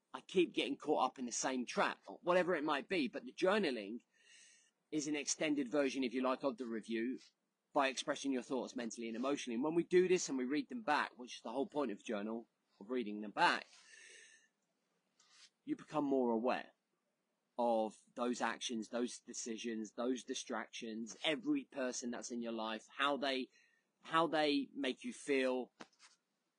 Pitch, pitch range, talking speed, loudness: 130 Hz, 120-155 Hz, 180 wpm, -39 LUFS